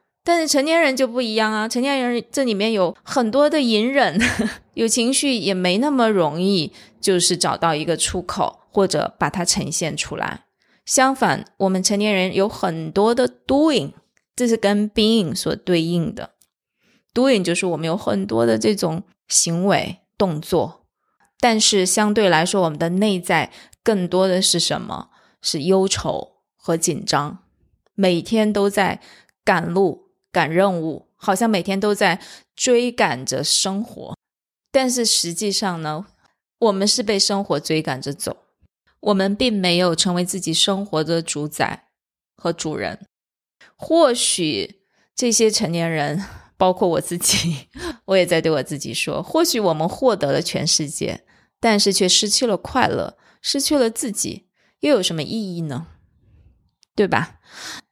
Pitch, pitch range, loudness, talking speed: 195 Hz, 170-225 Hz, -19 LUFS, 230 characters per minute